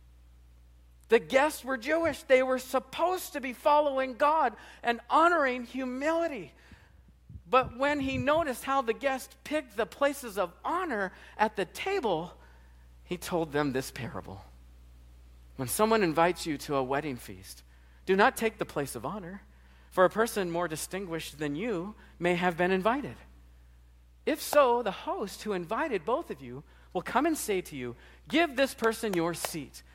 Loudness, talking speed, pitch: -29 LUFS, 160 wpm, 190 Hz